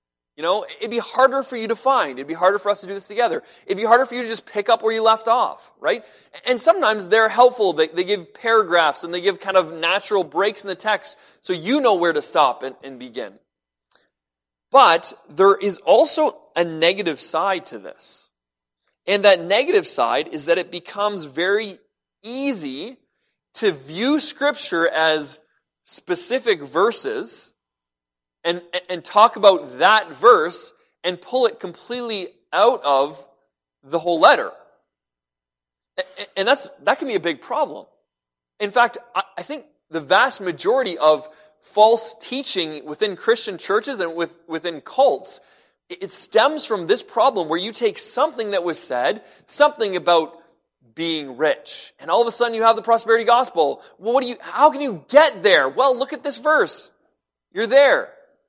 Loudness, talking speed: -19 LUFS, 170 wpm